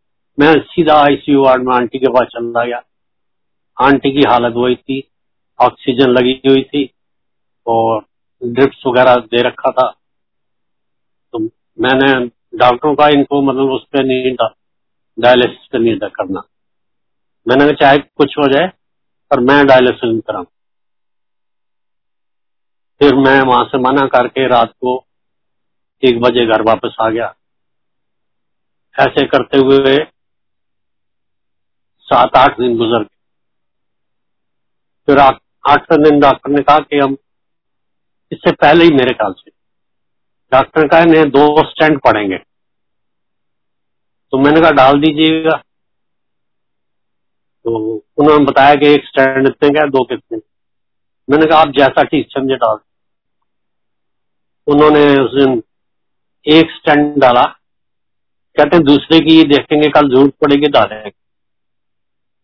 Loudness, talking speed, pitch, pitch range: -11 LUFS, 120 wpm, 135 Hz, 120-145 Hz